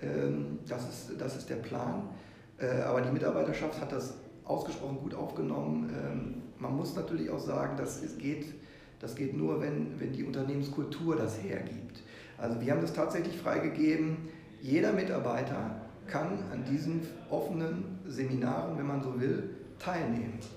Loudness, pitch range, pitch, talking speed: -35 LUFS, 100-155 Hz, 135 Hz, 145 wpm